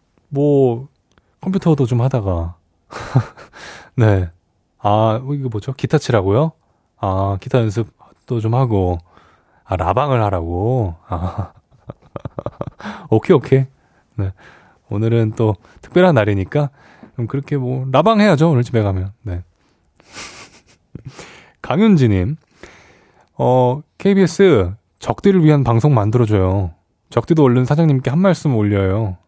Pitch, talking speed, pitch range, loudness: 115 Hz, 220 characters per minute, 100-140 Hz, -16 LUFS